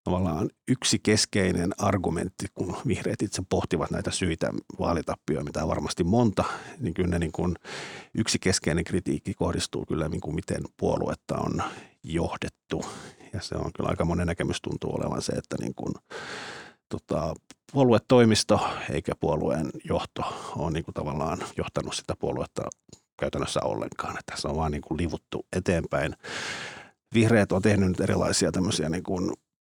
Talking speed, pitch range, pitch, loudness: 140 wpm, 85-100 Hz, 90 Hz, -28 LUFS